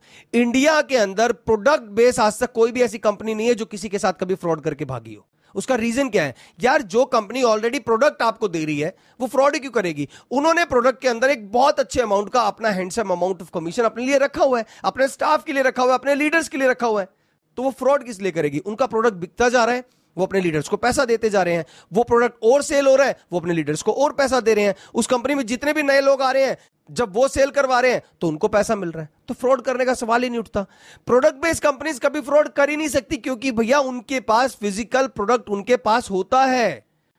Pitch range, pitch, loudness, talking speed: 205-270 Hz, 240 Hz, -20 LUFS, 255 wpm